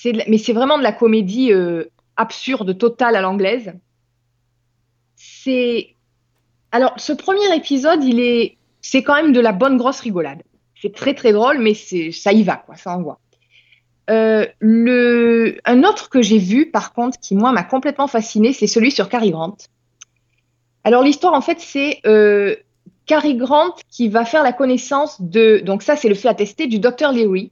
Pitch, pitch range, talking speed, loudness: 225 Hz, 190-260 Hz, 175 wpm, -16 LUFS